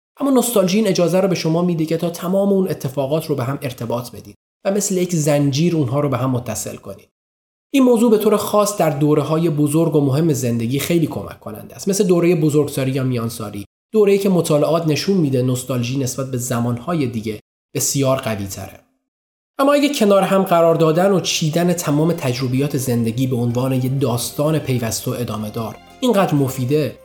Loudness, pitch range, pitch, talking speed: -18 LUFS, 125-175 Hz, 150 Hz, 180 wpm